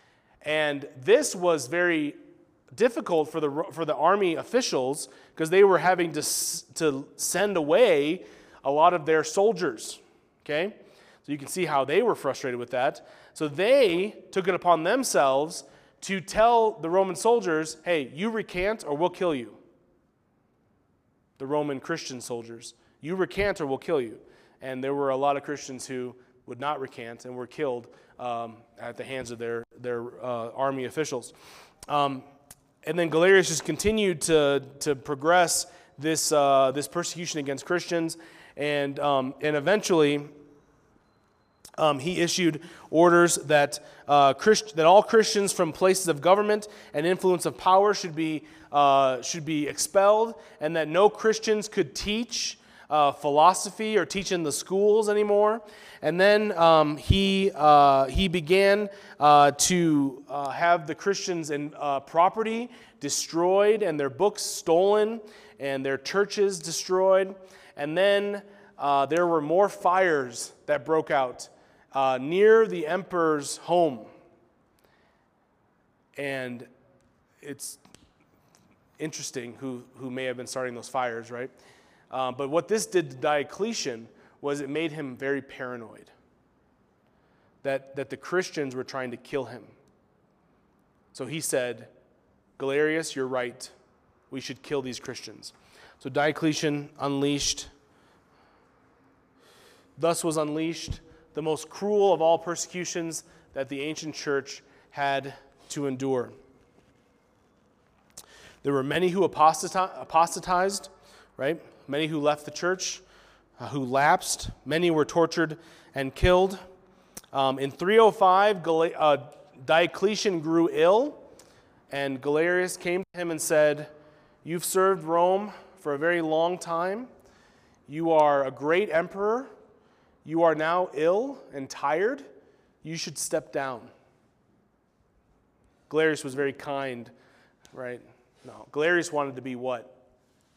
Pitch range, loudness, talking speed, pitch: 140-185 Hz, -25 LUFS, 135 wpm, 155 Hz